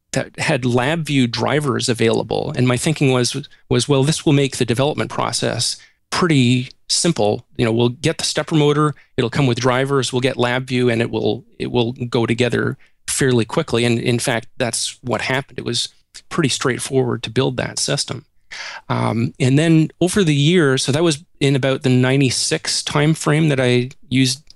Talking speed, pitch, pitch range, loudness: 180 wpm, 130 Hz, 120-150 Hz, -18 LUFS